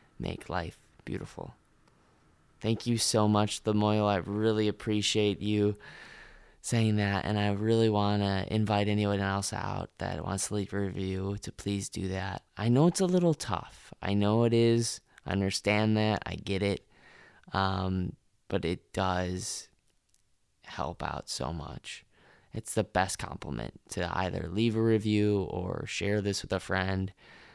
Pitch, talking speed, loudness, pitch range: 100 Hz, 155 wpm, -30 LUFS, 95-110 Hz